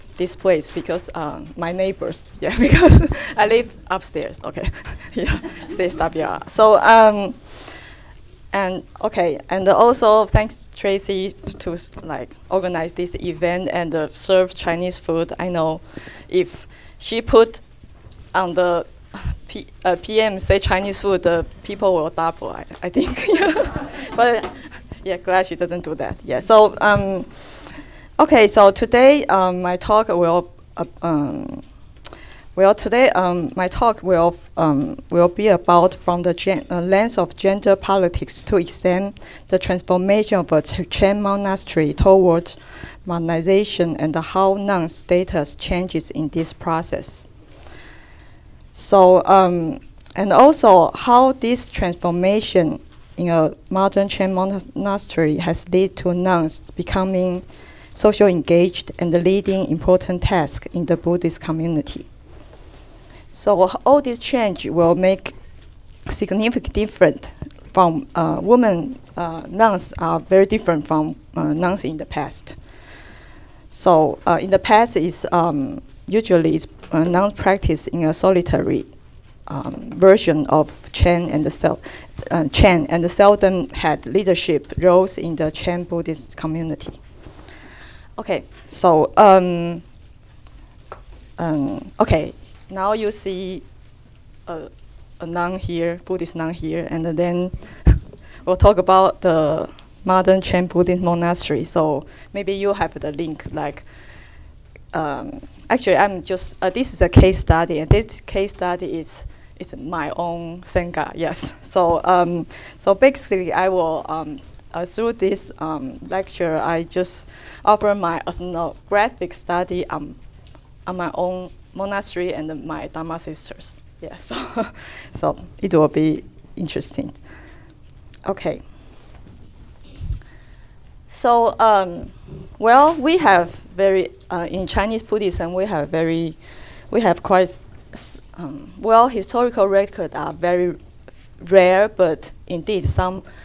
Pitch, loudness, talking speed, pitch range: 180 Hz, -18 LUFS, 130 wpm, 165-195 Hz